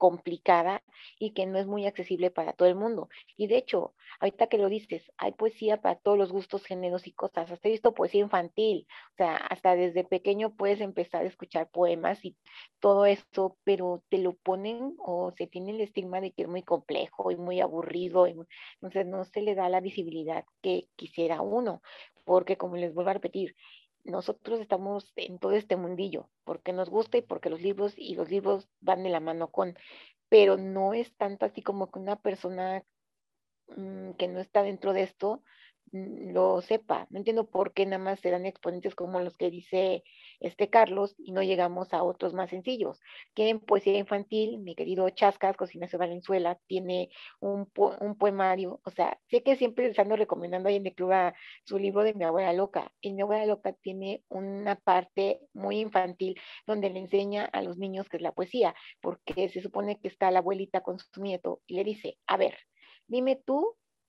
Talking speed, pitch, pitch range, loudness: 195 wpm, 190 Hz, 180-205 Hz, -30 LUFS